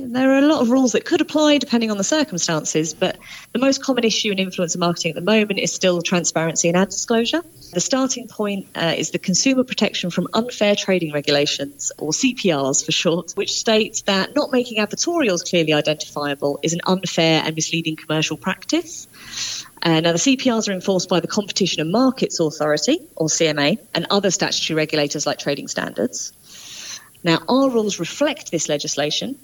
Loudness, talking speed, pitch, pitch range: -19 LUFS, 180 wpm, 185 Hz, 160-230 Hz